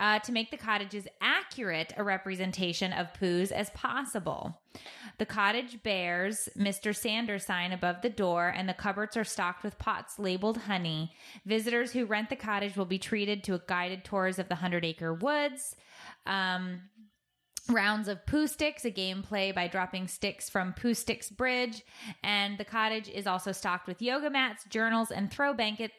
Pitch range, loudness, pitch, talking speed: 185-225 Hz, -32 LUFS, 205 Hz, 175 wpm